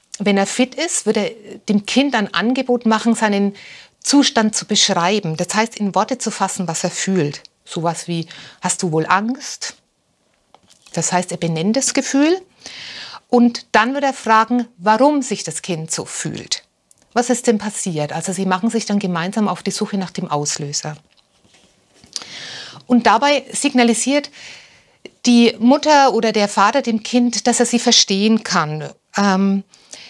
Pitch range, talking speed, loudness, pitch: 185-245 Hz, 160 wpm, -17 LUFS, 215 Hz